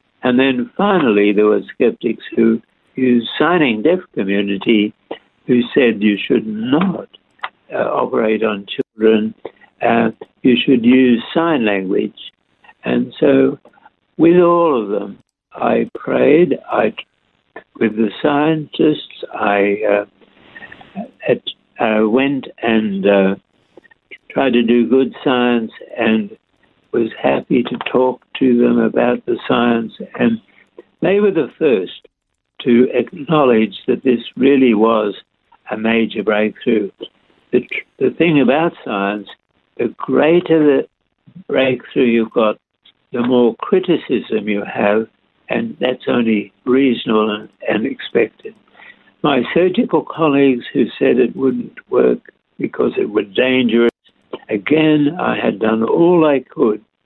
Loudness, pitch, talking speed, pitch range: -16 LUFS, 120 Hz, 120 wpm, 110-135 Hz